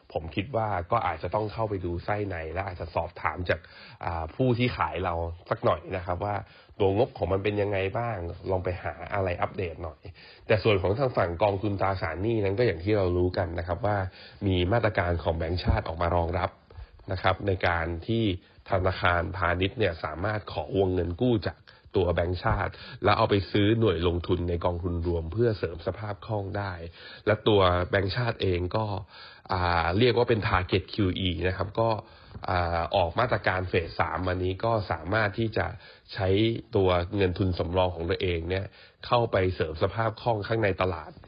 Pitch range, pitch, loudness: 90-105 Hz, 95 Hz, -28 LUFS